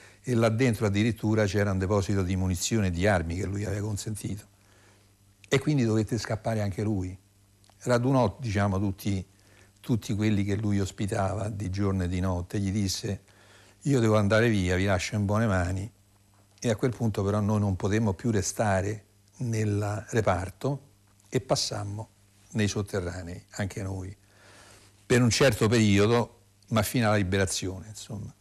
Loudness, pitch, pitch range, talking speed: -27 LUFS, 100 Hz, 100-110 Hz, 155 wpm